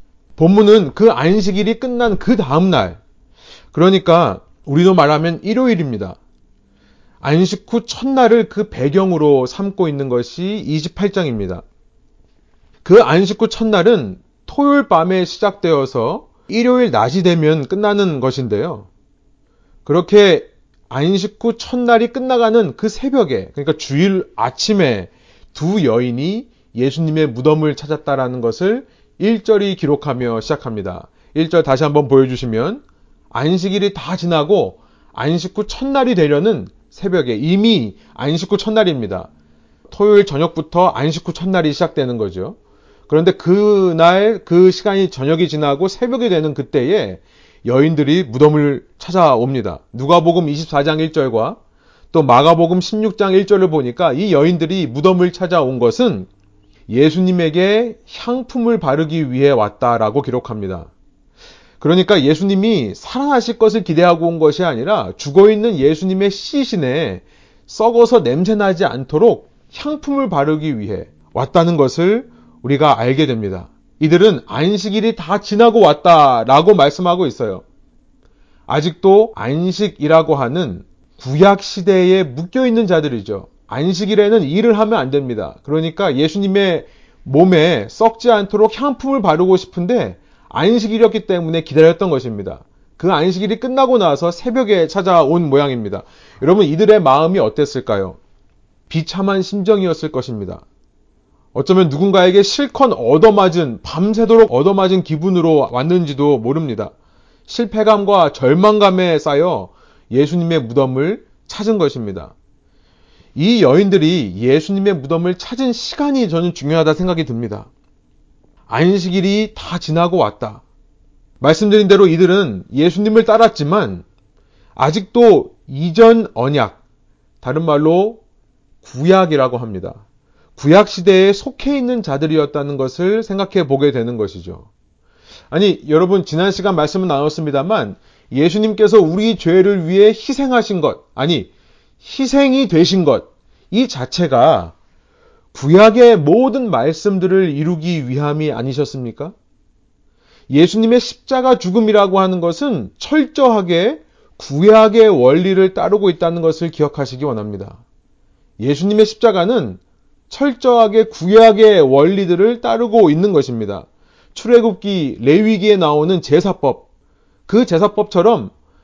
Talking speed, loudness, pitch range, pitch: 290 characters per minute, -14 LUFS, 145-215 Hz, 180 Hz